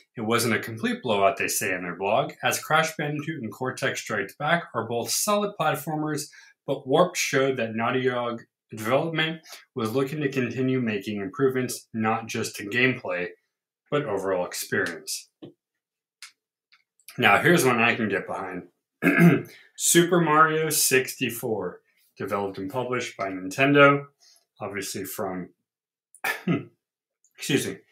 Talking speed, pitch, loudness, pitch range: 130 wpm, 130 Hz, -24 LUFS, 115-150 Hz